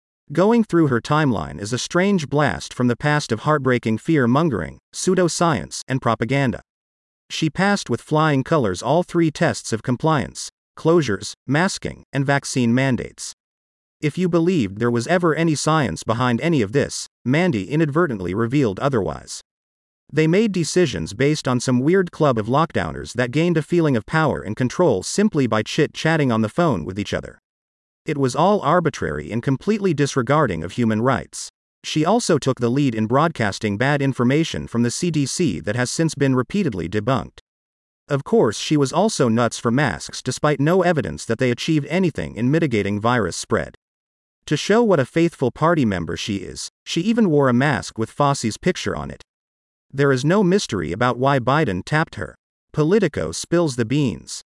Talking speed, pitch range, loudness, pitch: 170 wpm, 120-165 Hz, -20 LUFS, 140 Hz